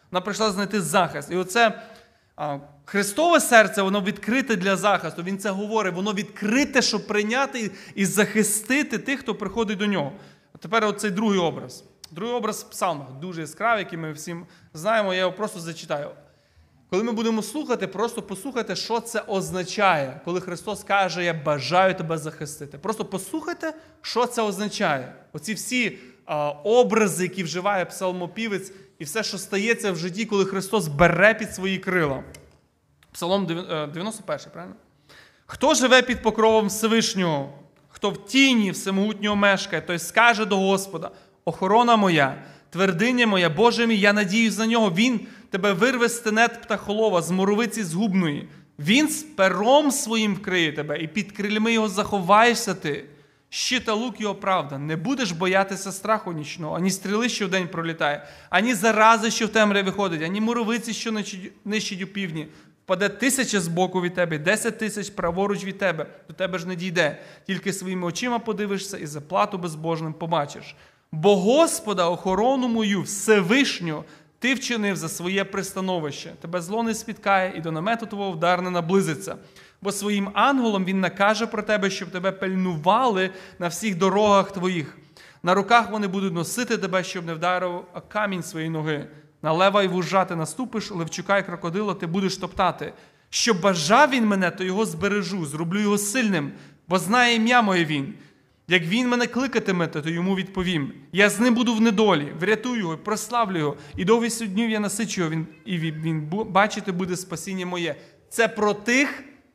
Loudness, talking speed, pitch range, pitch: -23 LUFS, 155 wpm, 175-220 Hz, 195 Hz